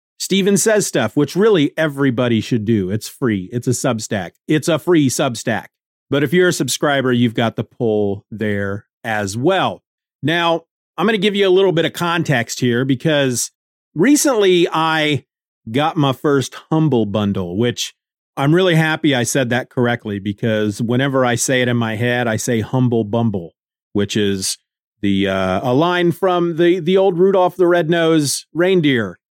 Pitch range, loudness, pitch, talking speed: 115-170 Hz, -17 LUFS, 135 Hz, 170 wpm